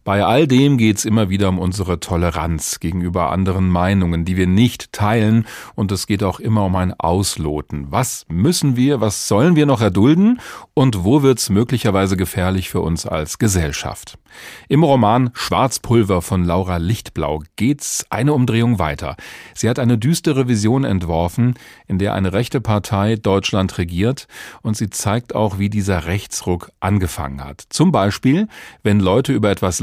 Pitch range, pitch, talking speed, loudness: 90-120 Hz, 100 Hz, 160 wpm, -17 LUFS